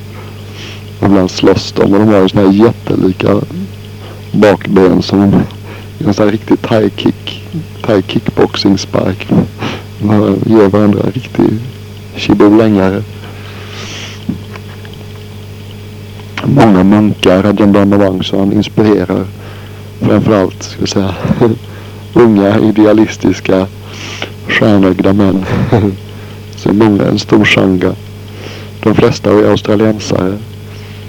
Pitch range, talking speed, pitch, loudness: 100-105 Hz, 90 wpm, 105 Hz, -10 LUFS